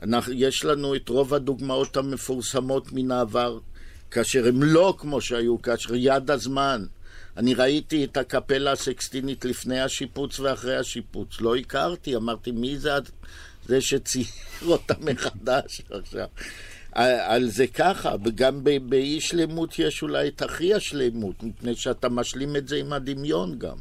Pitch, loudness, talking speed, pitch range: 130 Hz, -25 LUFS, 135 wpm, 120-140 Hz